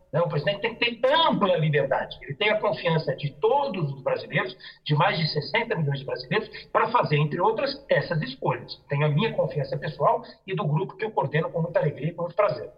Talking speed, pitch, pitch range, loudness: 220 wpm, 170 Hz, 150-225 Hz, -25 LUFS